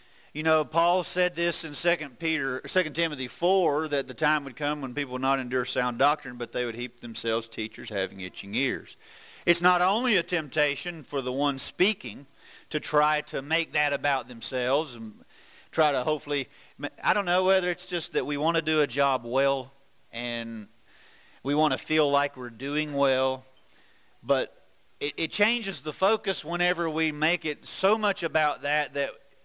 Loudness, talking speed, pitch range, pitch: -27 LUFS, 180 wpm, 130-165 Hz, 150 Hz